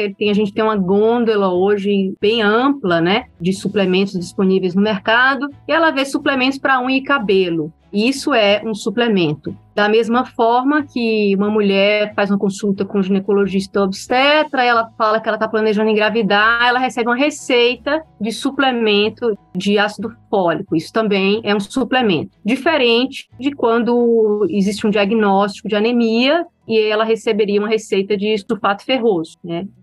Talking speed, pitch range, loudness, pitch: 155 wpm, 200-240 Hz, -16 LUFS, 215 Hz